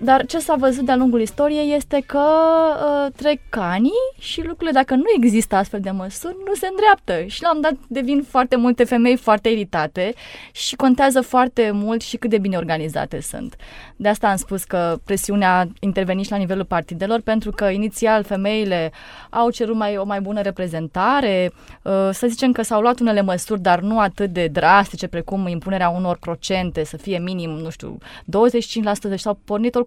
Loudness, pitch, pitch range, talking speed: -19 LUFS, 215 Hz, 190-255 Hz, 185 wpm